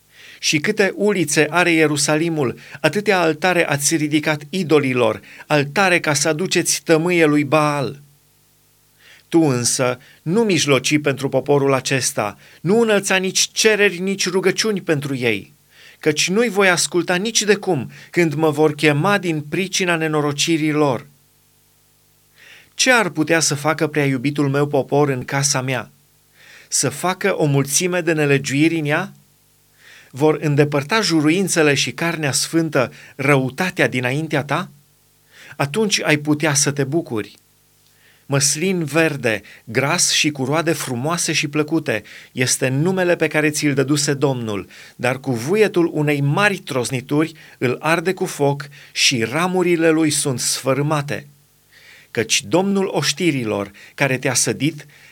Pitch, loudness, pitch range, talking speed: 150 Hz, -18 LUFS, 140-170 Hz, 130 wpm